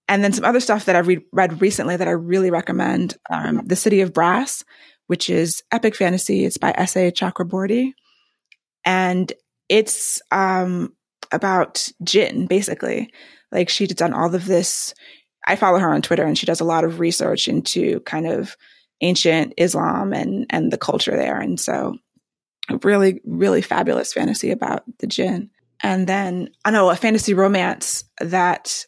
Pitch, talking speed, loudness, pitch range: 185 Hz, 160 wpm, -19 LUFS, 175-210 Hz